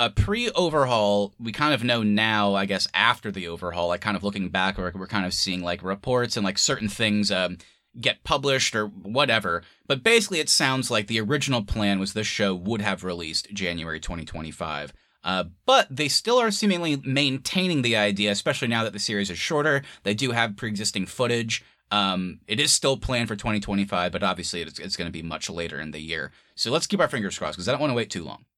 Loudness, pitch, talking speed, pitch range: -24 LUFS, 105 Hz, 220 wpm, 95-125 Hz